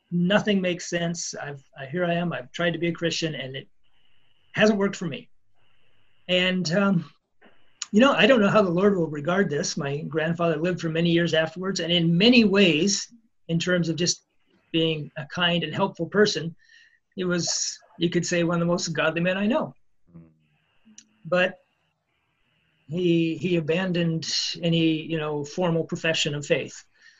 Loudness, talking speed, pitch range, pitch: -24 LUFS, 170 wpm, 160-185 Hz, 170 Hz